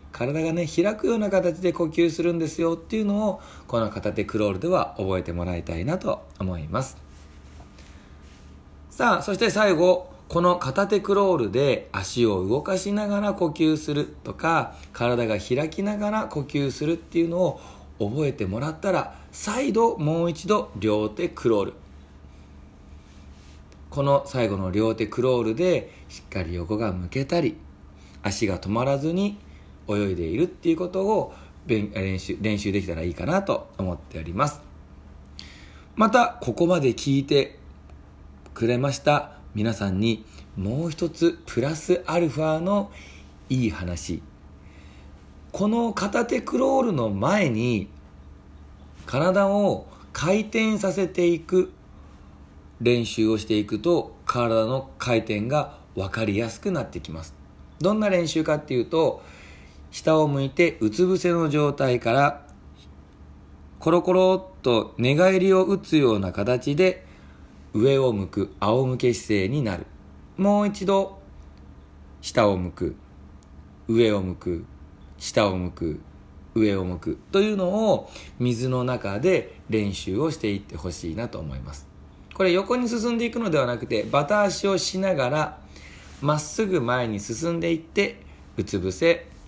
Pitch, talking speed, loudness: 110 Hz, 265 characters per minute, -24 LUFS